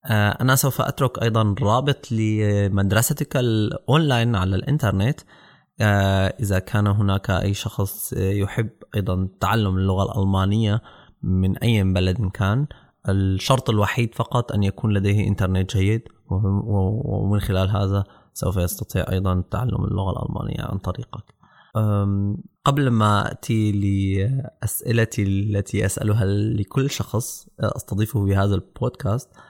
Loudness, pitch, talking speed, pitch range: -22 LUFS, 105 Hz, 110 wpm, 100-115 Hz